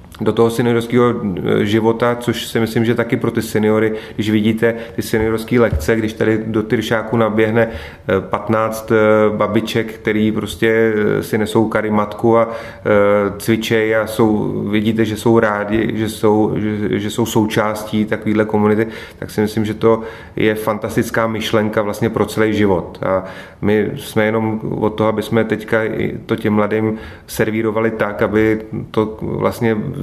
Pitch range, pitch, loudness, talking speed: 105-115 Hz, 110 Hz, -16 LUFS, 150 wpm